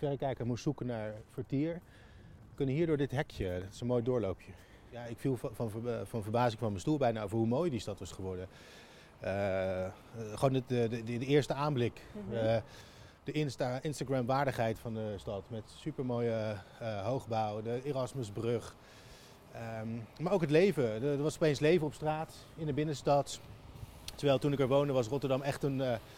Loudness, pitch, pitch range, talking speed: -35 LUFS, 120 Hz, 110-140 Hz, 180 wpm